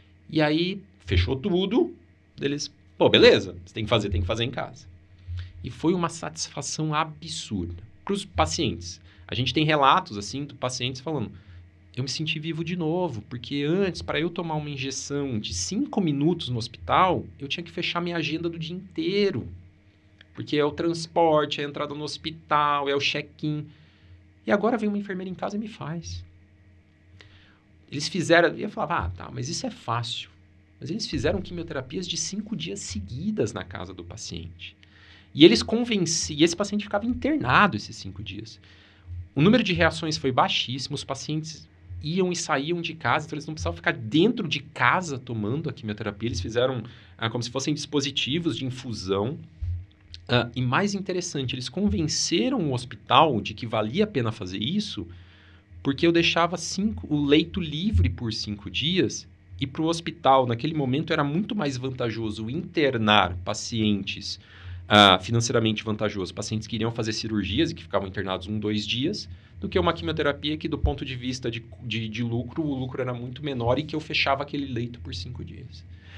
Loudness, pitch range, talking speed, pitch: -25 LUFS, 100-160 Hz, 175 wpm, 125 Hz